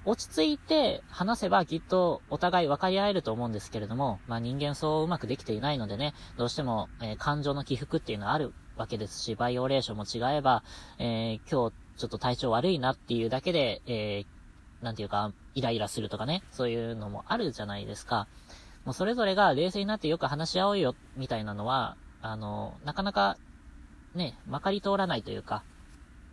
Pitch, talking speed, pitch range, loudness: 120 Hz, 415 characters per minute, 105-155 Hz, -31 LUFS